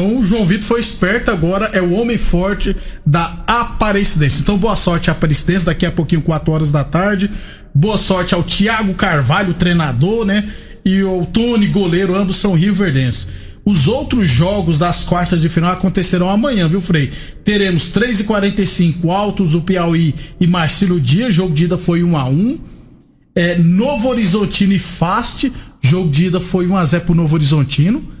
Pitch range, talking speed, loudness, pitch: 165-205 Hz, 170 wpm, -14 LUFS, 185 Hz